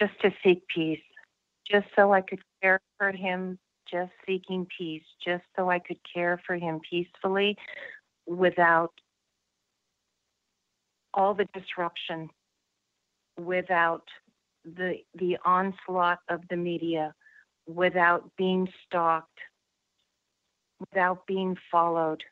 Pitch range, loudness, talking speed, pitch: 170-190 Hz, -28 LUFS, 105 wpm, 180 Hz